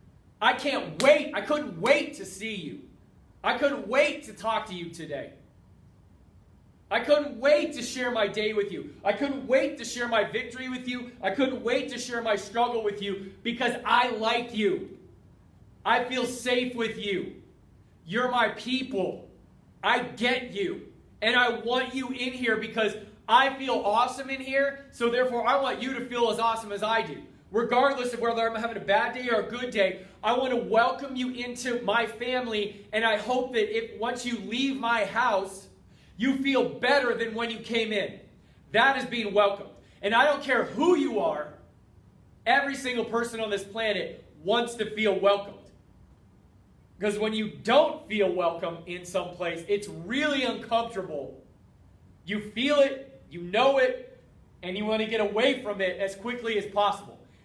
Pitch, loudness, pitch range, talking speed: 230 Hz, -27 LUFS, 205-255 Hz, 180 wpm